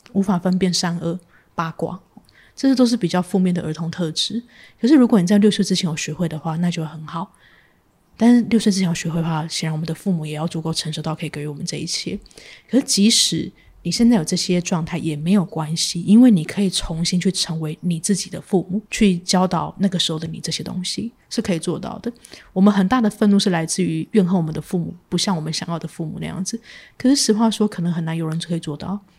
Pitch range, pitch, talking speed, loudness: 165-205 Hz, 180 Hz, 355 characters per minute, -20 LUFS